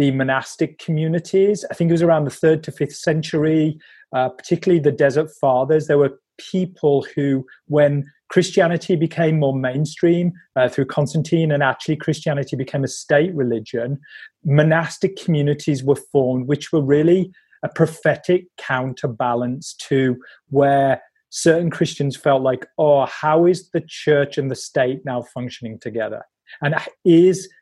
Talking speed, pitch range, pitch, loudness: 145 wpm, 135-165 Hz, 150 Hz, -19 LUFS